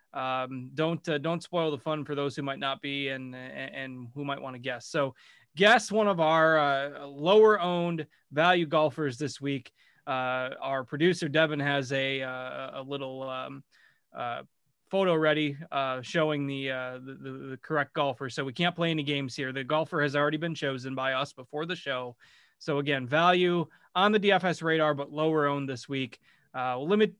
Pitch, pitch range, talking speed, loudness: 145 Hz, 135-160 Hz, 195 wpm, -28 LUFS